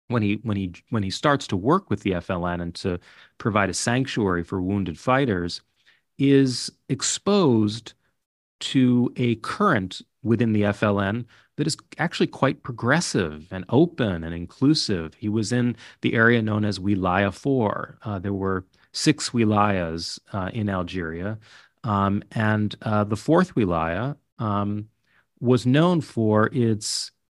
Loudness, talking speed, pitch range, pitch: -23 LUFS, 145 wpm, 100-125 Hz, 110 Hz